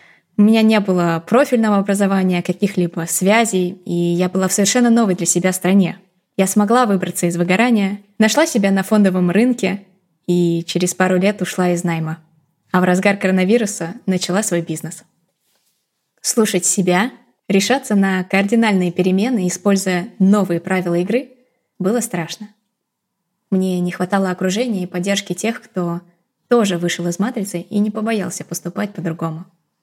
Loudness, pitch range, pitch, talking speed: -17 LUFS, 175-210 Hz, 190 Hz, 140 wpm